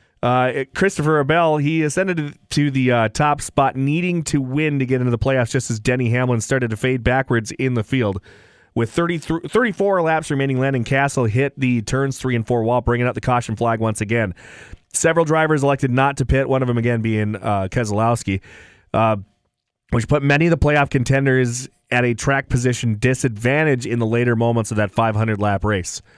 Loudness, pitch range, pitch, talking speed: -19 LUFS, 115-140 Hz, 125 Hz, 195 wpm